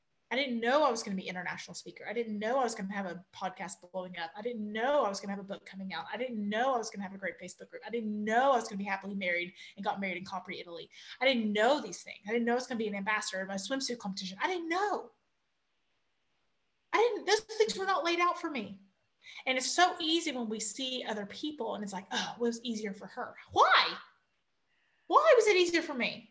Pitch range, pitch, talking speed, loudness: 195-270 Hz, 225 Hz, 275 wpm, -32 LUFS